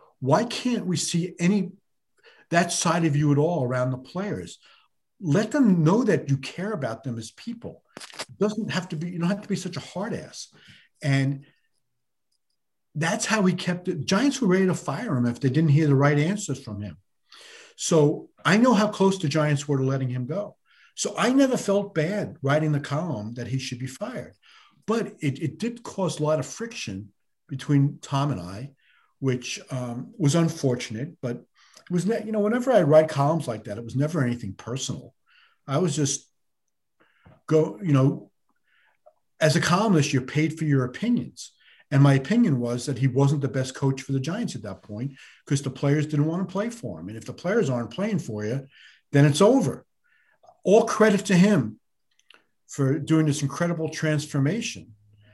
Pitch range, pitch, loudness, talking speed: 130-185 Hz, 150 Hz, -24 LUFS, 190 wpm